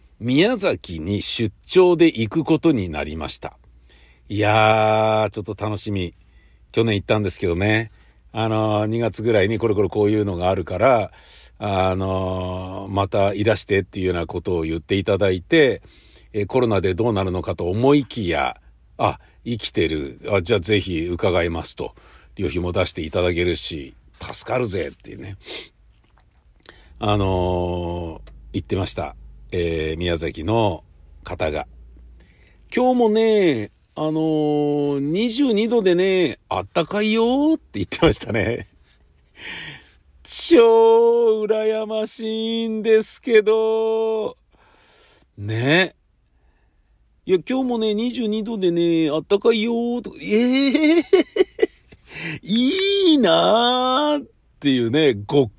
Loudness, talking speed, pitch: -20 LUFS, 245 characters per minute, 110 Hz